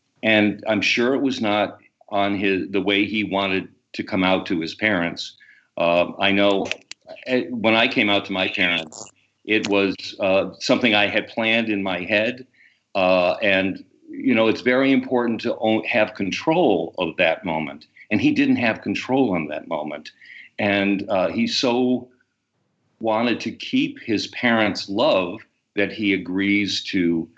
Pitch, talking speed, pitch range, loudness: 105 Hz, 160 wpm, 100-125 Hz, -21 LUFS